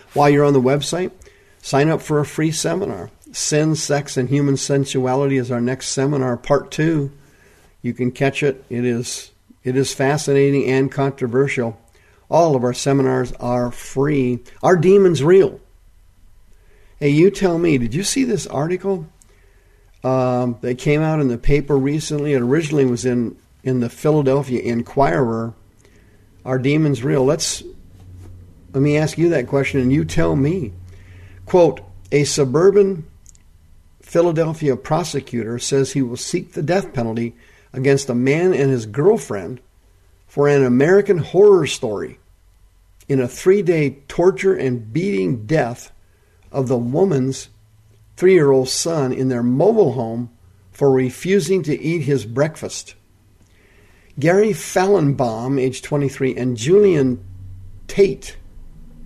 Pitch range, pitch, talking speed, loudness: 110-150 Hz, 130 Hz, 140 wpm, -18 LUFS